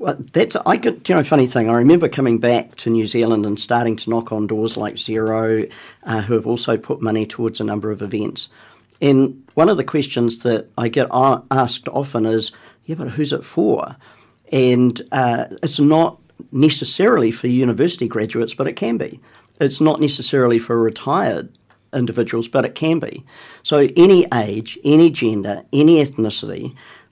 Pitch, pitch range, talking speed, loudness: 120 Hz, 110-140 Hz, 175 wpm, -17 LUFS